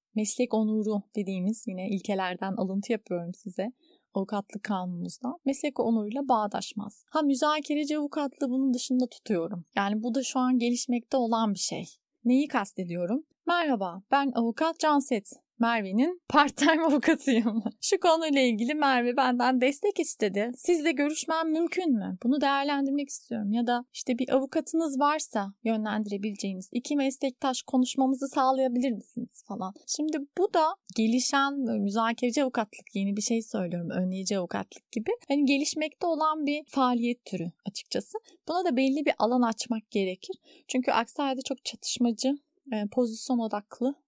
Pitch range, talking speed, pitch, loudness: 215-285 Hz, 130 wpm, 250 Hz, -28 LUFS